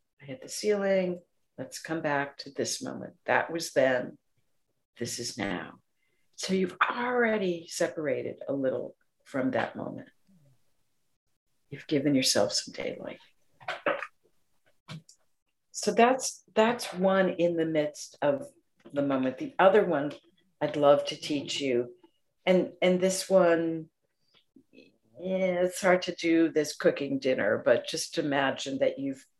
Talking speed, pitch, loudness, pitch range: 135 wpm, 165 Hz, -28 LUFS, 140-190 Hz